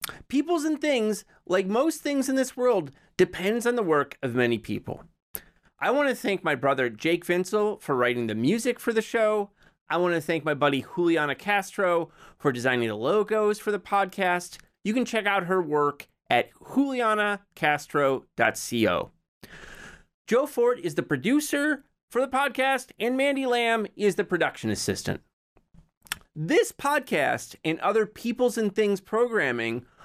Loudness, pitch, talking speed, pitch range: -26 LUFS, 200 Hz, 155 wpm, 160-240 Hz